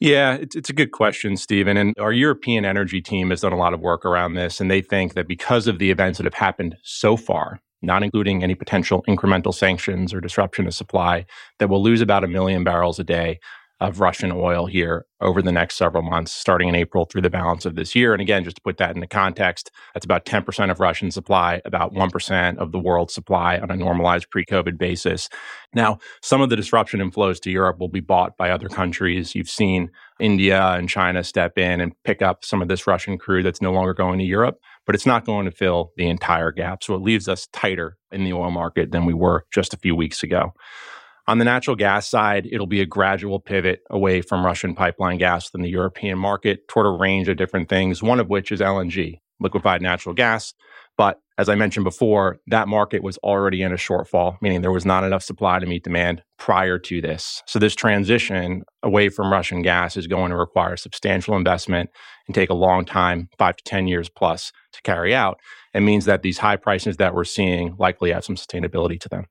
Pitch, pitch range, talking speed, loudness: 95 Hz, 90-100 Hz, 220 wpm, -20 LUFS